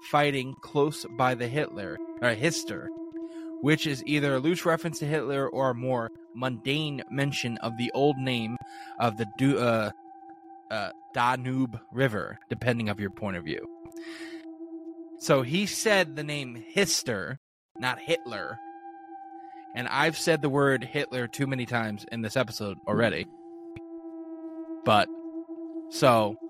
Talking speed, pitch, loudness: 135 wpm, 150 Hz, -28 LUFS